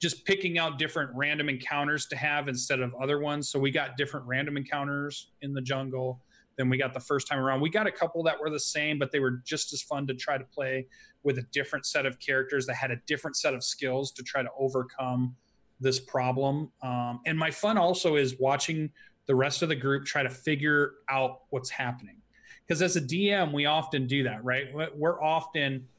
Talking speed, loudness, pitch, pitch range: 215 wpm, -29 LUFS, 140 Hz, 130-150 Hz